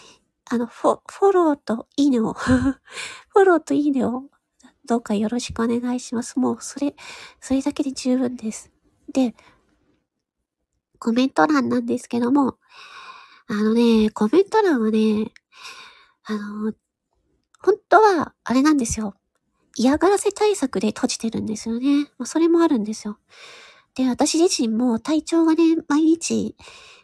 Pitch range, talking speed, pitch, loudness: 235-350 Hz, 265 characters per minute, 270 Hz, -21 LUFS